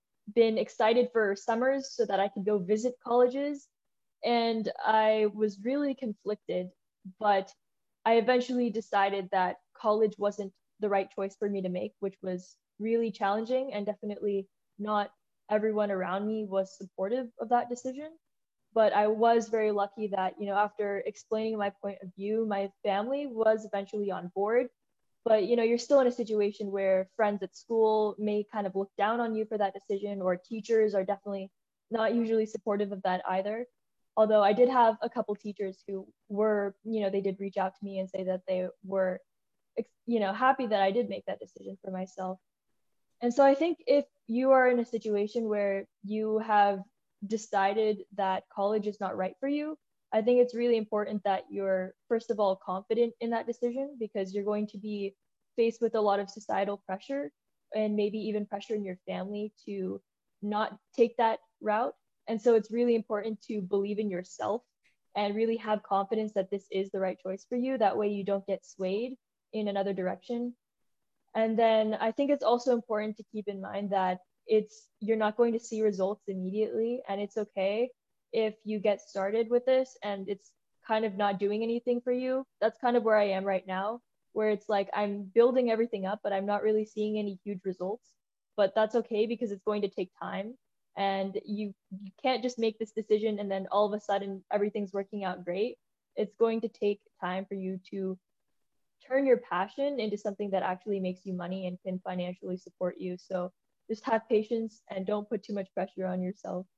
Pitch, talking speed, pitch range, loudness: 210 Hz, 190 wpm, 195-225 Hz, -30 LUFS